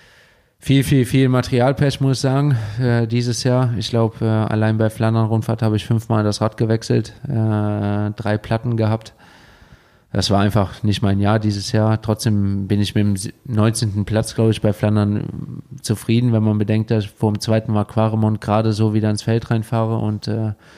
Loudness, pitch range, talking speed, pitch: -19 LUFS, 105-115 Hz, 185 wpm, 110 Hz